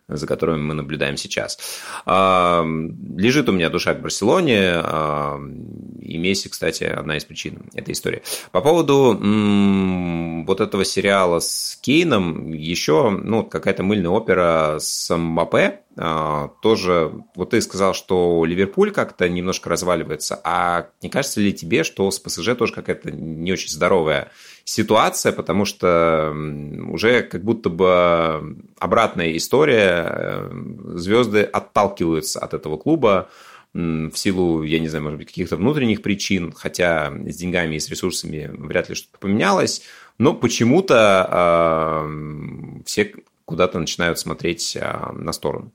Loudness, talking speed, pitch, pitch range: -19 LUFS, 130 wpm, 85 Hz, 80-95 Hz